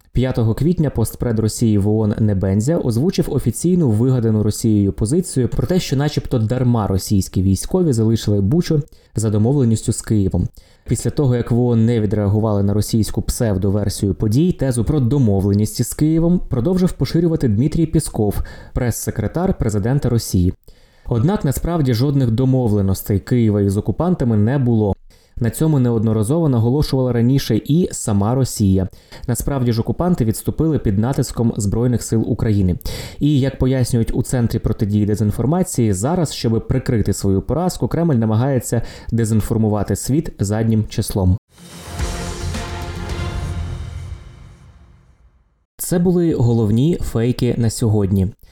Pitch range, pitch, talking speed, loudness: 105-135 Hz, 115 Hz, 120 wpm, -18 LUFS